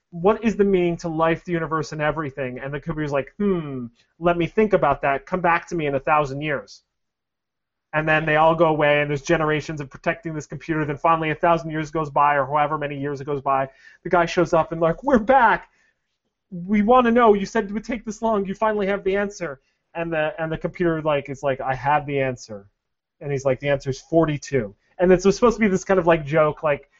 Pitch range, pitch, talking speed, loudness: 145-180 Hz, 160 Hz, 245 wpm, -21 LUFS